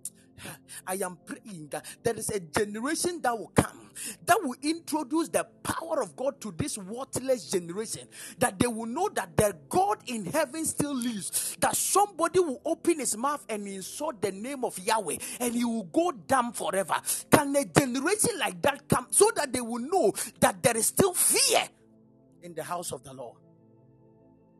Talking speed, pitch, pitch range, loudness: 180 wpm, 245 Hz, 205-310 Hz, -28 LUFS